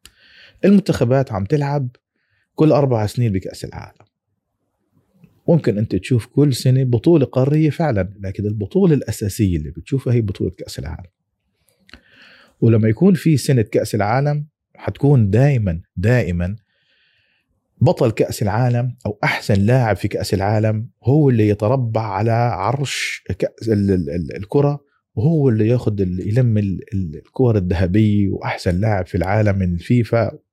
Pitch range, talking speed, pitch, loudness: 100-135 Hz, 125 wpm, 115 Hz, -18 LUFS